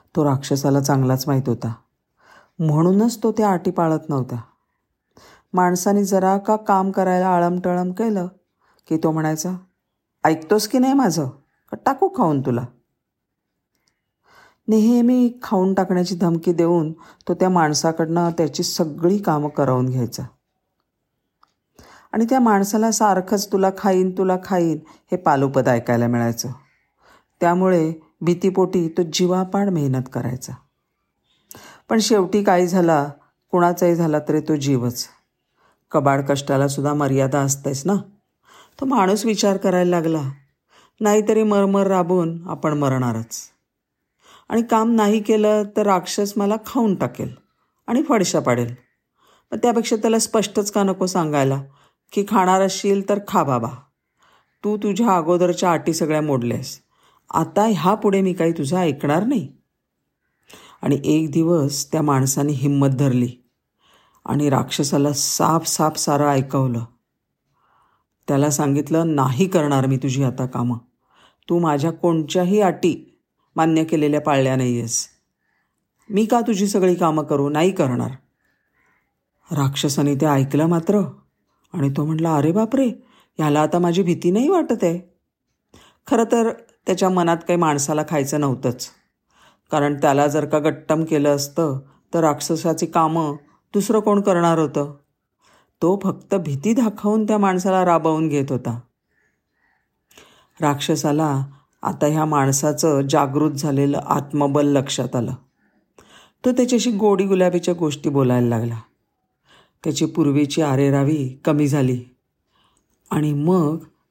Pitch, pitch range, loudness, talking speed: 165 Hz, 140-190 Hz, -19 LUFS, 120 wpm